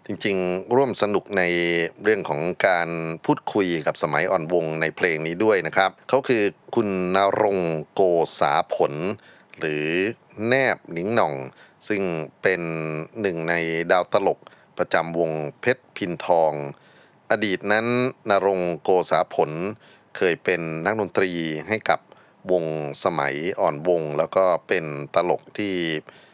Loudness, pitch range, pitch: -23 LUFS, 80-95 Hz, 85 Hz